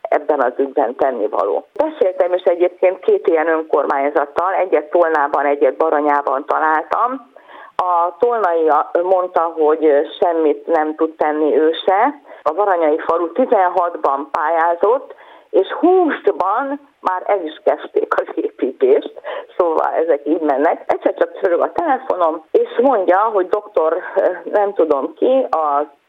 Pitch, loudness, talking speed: 185 Hz, -16 LUFS, 125 wpm